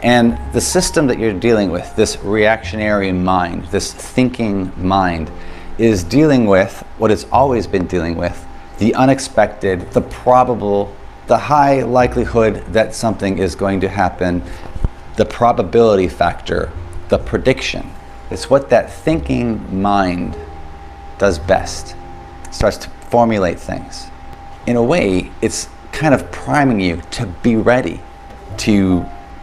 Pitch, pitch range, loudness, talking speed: 100 Hz, 90-115 Hz, -16 LUFS, 130 wpm